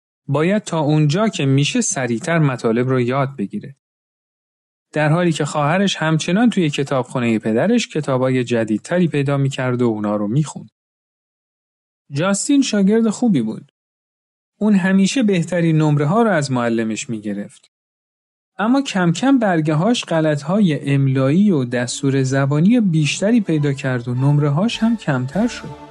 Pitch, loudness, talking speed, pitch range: 150 Hz, -17 LUFS, 135 wpm, 130-195 Hz